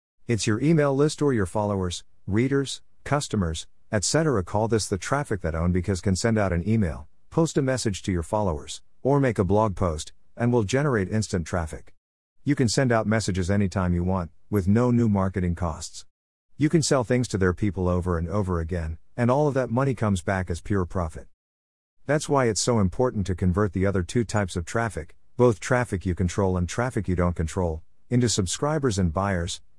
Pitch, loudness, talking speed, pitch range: 100 Hz, -25 LUFS, 195 wpm, 90-120 Hz